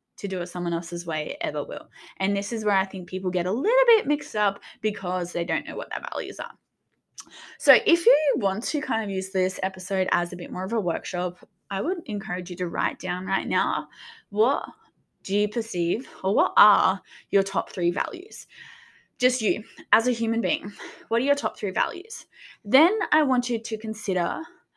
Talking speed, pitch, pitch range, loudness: 205 wpm, 205 Hz, 185-250 Hz, -25 LUFS